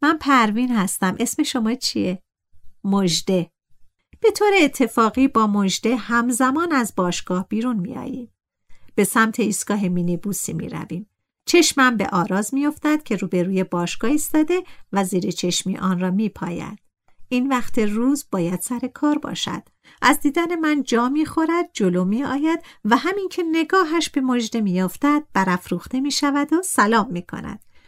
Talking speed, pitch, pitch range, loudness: 155 wpm, 235 Hz, 190-290 Hz, -20 LUFS